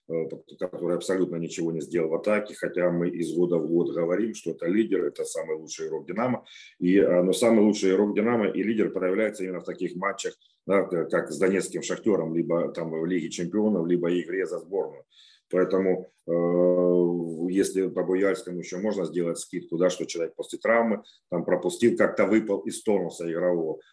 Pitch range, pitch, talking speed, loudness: 85-110 Hz, 90 Hz, 175 wpm, -26 LUFS